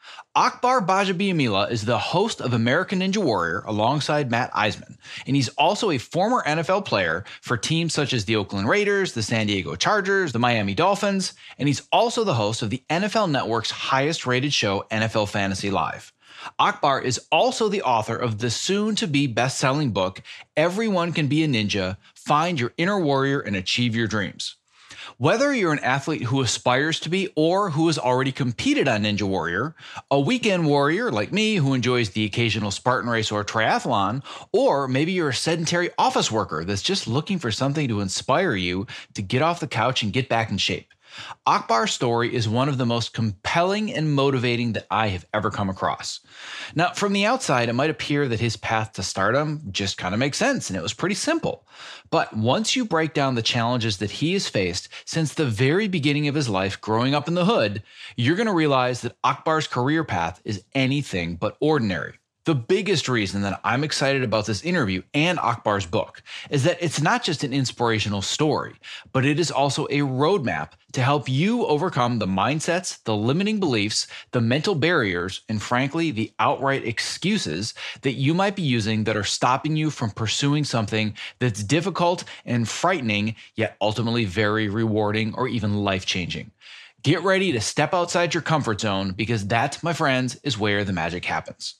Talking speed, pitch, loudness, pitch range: 185 wpm, 125 Hz, -23 LUFS, 110-160 Hz